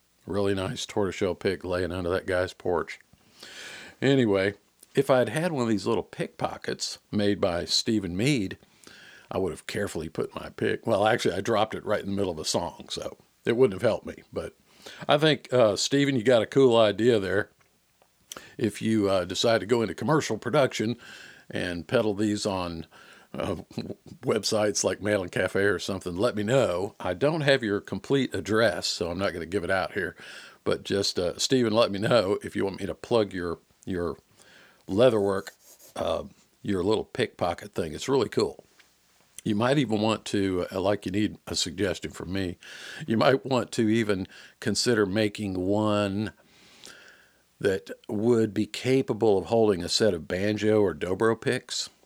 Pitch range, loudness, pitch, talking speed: 95-115 Hz, -26 LUFS, 105 Hz, 180 wpm